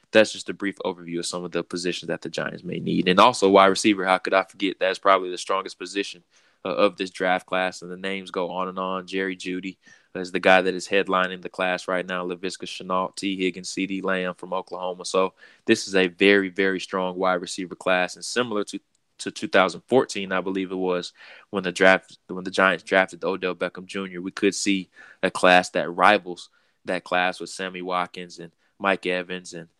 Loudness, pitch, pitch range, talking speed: -23 LUFS, 95 Hz, 90-95 Hz, 215 wpm